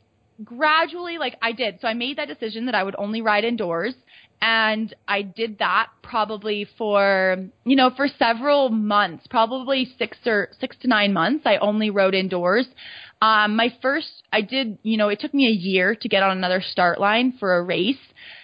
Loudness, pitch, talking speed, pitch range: -21 LUFS, 220 Hz, 190 wpm, 200-255 Hz